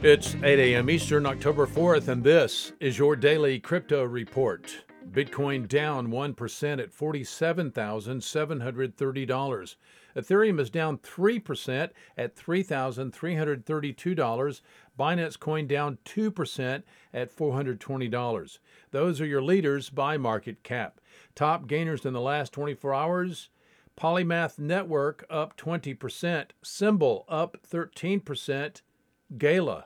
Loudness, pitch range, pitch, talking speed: -28 LUFS, 135-165 Hz, 145 Hz, 105 wpm